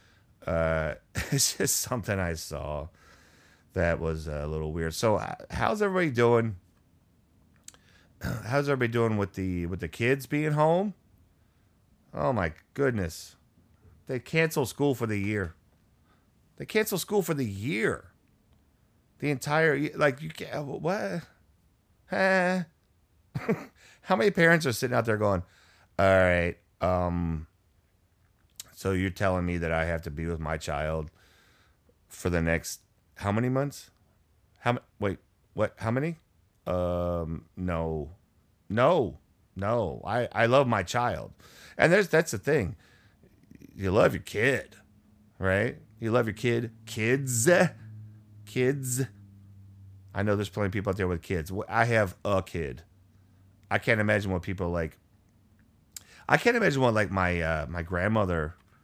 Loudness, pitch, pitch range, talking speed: -28 LUFS, 100 Hz, 90-125 Hz, 140 wpm